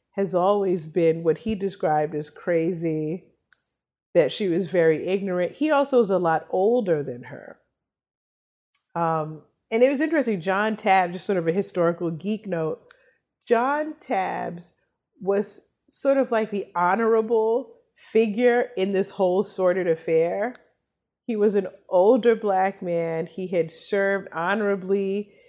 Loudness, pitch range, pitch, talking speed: -23 LUFS, 170-220 Hz, 190 Hz, 140 wpm